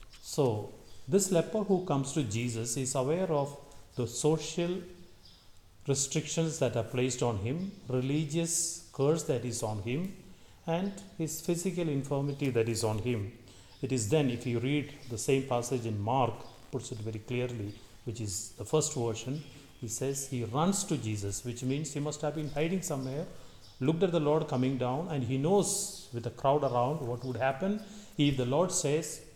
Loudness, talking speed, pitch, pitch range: -32 LUFS, 175 wpm, 135 Hz, 120-155 Hz